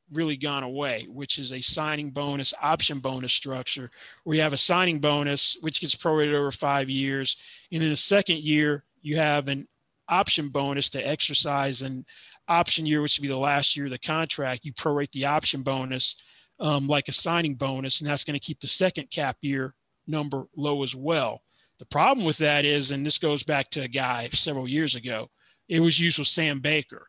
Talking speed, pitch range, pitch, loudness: 200 wpm, 135-155 Hz, 145 Hz, -24 LUFS